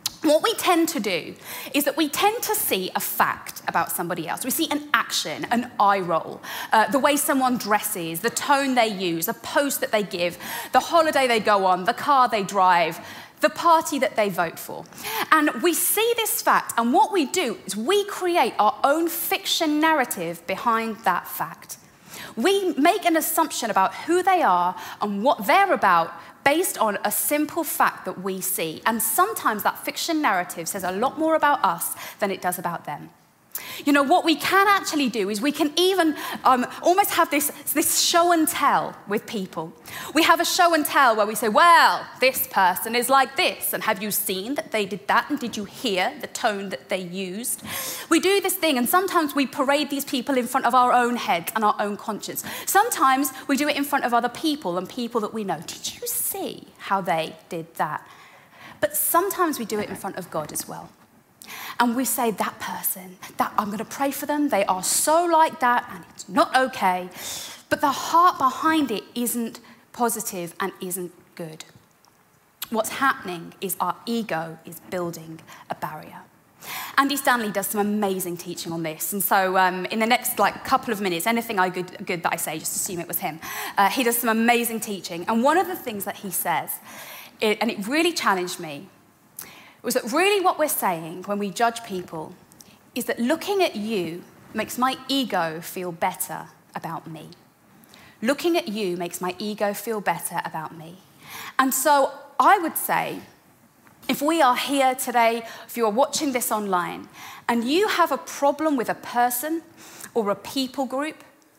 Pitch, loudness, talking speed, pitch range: 240 Hz, -22 LUFS, 195 wpm, 195-305 Hz